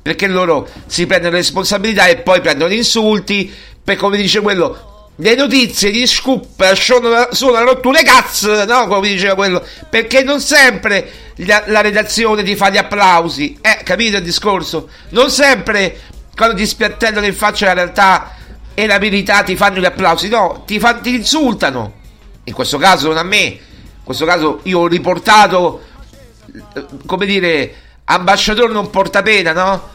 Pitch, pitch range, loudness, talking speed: 200 Hz, 180-220 Hz, -11 LUFS, 165 wpm